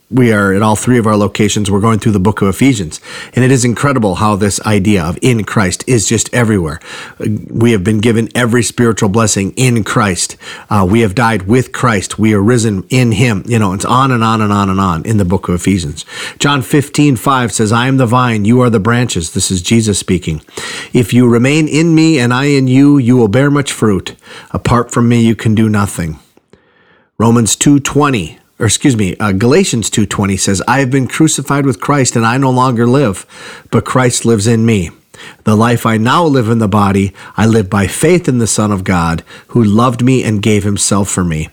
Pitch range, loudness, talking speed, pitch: 100-125 Hz, -11 LUFS, 220 wpm, 115 Hz